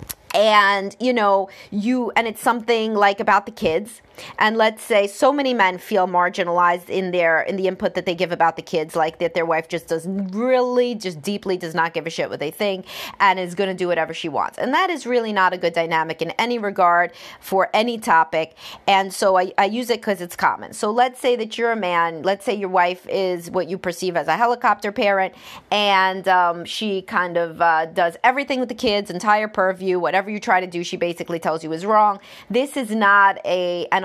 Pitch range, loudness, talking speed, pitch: 175-215 Hz, -20 LUFS, 220 wpm, 190 Hz